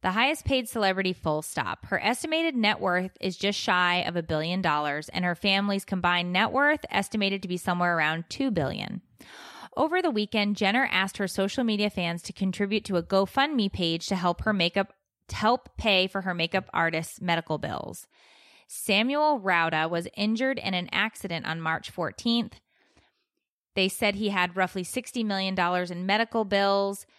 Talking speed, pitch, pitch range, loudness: 170 wpm, 195 Hz, 175-215 Hz, -26 LUFS